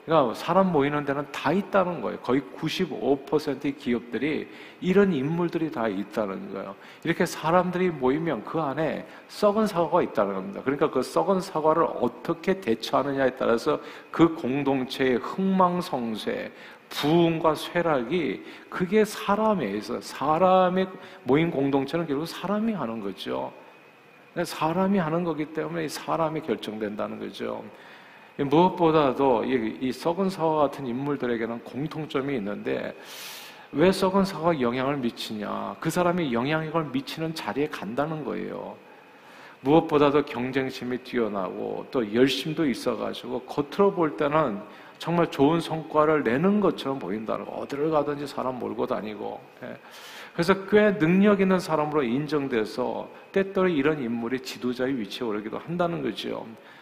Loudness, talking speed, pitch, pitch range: -26 LUFS, 320 characters per minute, 155 Hz, 130-175 Hz